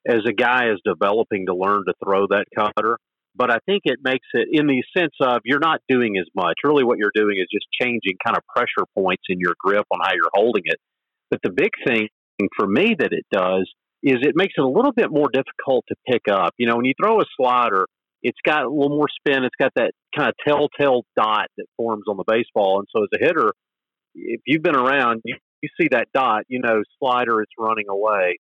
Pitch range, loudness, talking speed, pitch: 105-140 Hz, -20 LUFS, 235 wpm, 120 Hz